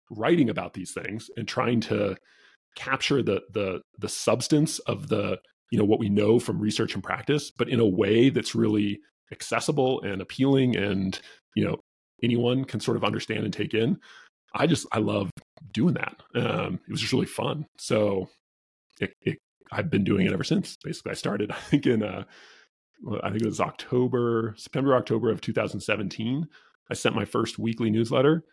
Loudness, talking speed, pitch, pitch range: -26 LUFS, 180 wpm, 115 Hz, 110-130 Hz